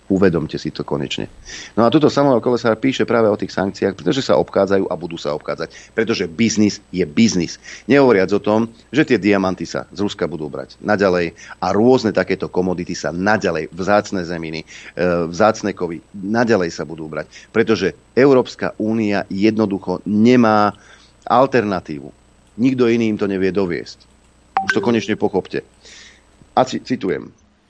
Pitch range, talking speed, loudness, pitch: 90-110 Hz, 155 wpm, -18 LUFS, 100 Hz